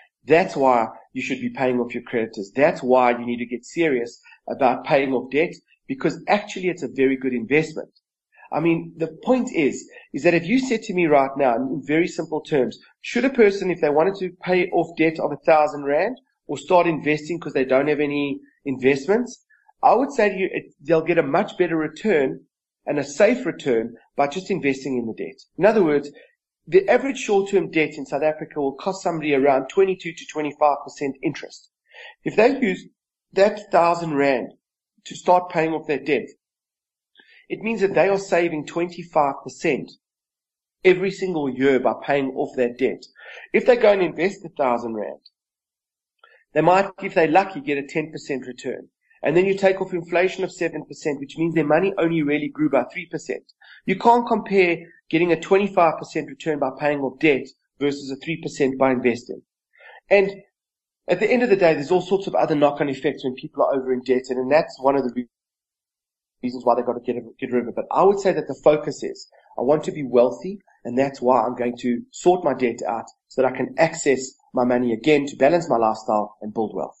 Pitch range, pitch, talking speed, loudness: 135-185 Hz, 155 Hz, 200 wpm, -21 LUFS